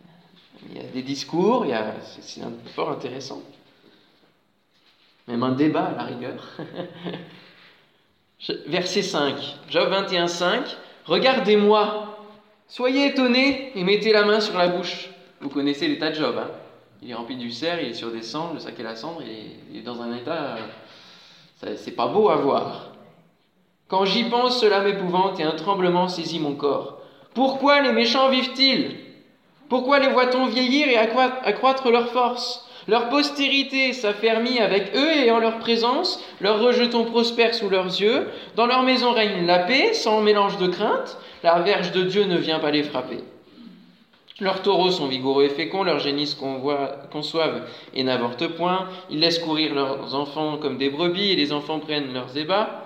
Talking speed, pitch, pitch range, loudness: 165 wpm, 195 Hz, 155-240 Hz, -21 LUFS